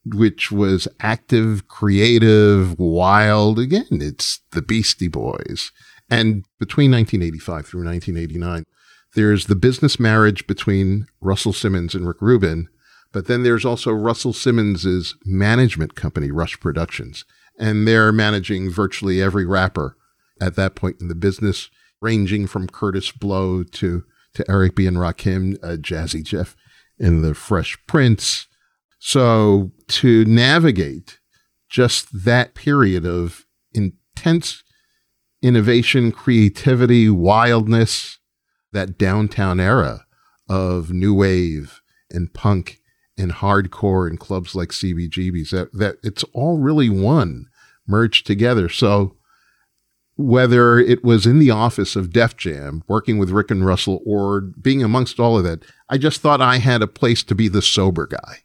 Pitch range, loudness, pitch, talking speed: 95-115 Hz, -17 LUFS, 100 Hz, 135 wpm